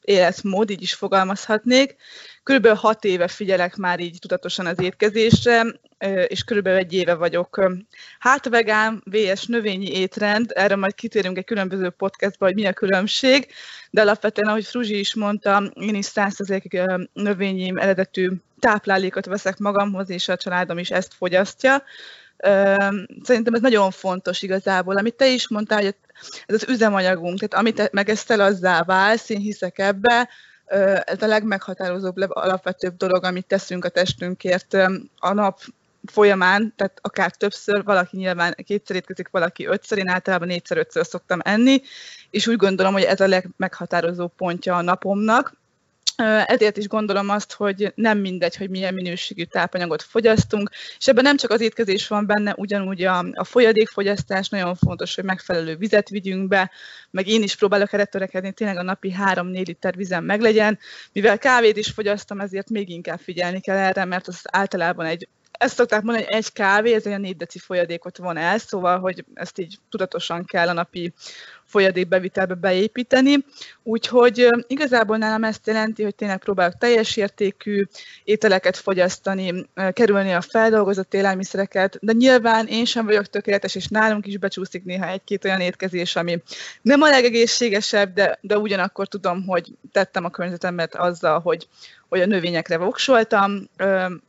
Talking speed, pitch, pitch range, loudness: 155 wpm, 195 Hz, 185-215 Hz, -20 LUFS